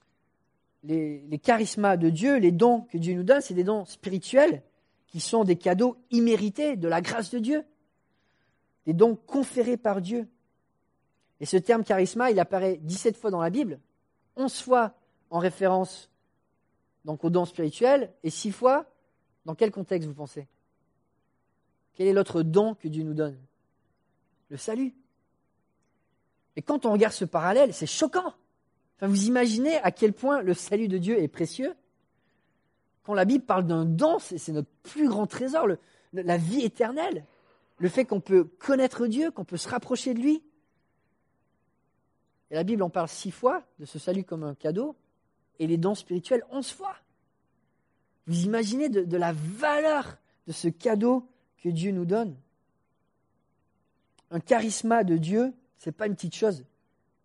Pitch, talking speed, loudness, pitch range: 205 Hz, 165 wpm, -26 LUFS, 170-245 Hz